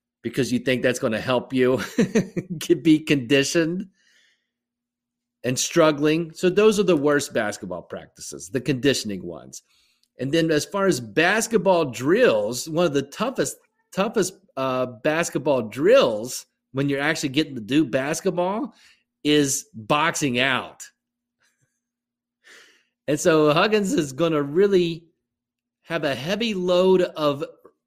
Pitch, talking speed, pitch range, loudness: 155 Hz, 130 wpm, 130-185 Hz, -22 LUFS